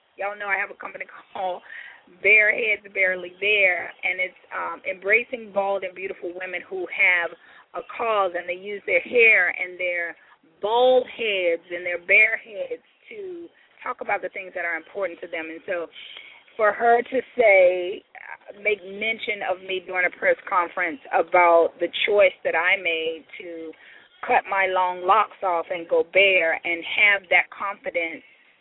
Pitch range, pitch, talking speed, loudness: 180-220 Hz, 195 Hz, 165 wpm, -21 LUFS